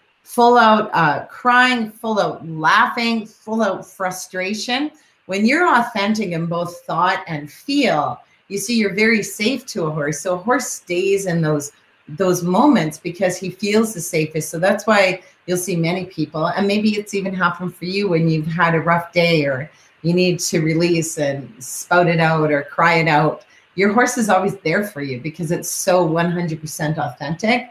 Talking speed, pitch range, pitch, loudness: 185 wpm, 165-210 Hz, 180 Hz, -18 LUFS